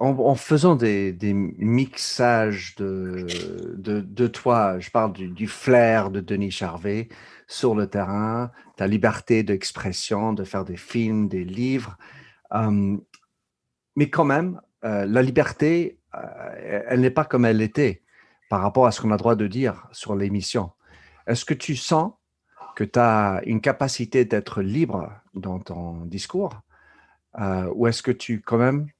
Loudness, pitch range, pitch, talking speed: -23 LUFS, 100-125 Hz, 110 Hz, 155 wpm